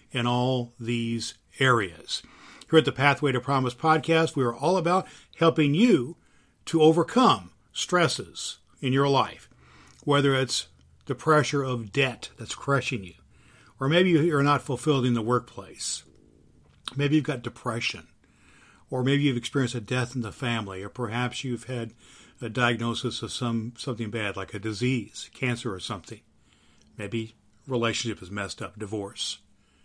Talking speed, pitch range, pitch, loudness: 150 wpm, 110-140 Hz, 120 Hz, -26 LUFS